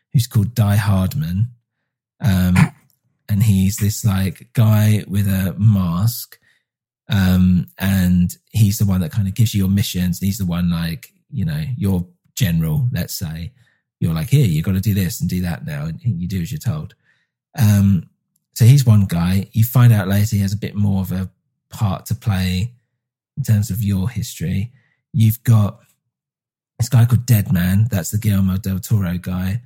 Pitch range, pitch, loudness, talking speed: 95-125 Hz, 105 Hz, -18 LUFS, 185 wpm